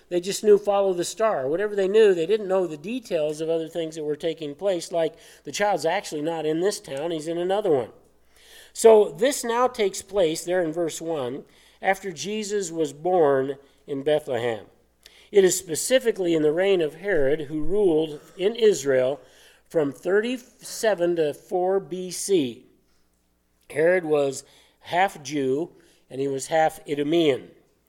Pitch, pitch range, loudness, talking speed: 170 Hz, 150-200 Hz, -24 LUFS, 160 wpm